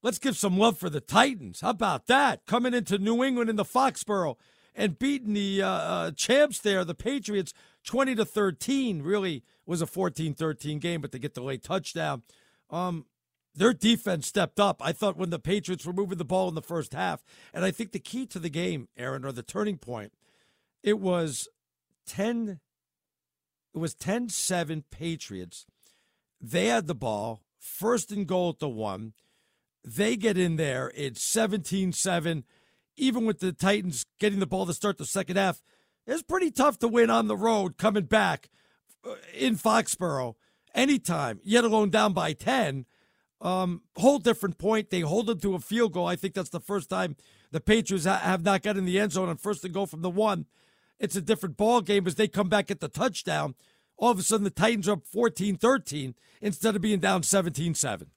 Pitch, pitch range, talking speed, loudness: 195 Hz, 165-220 Hz, 190 wpm, -27 LUFS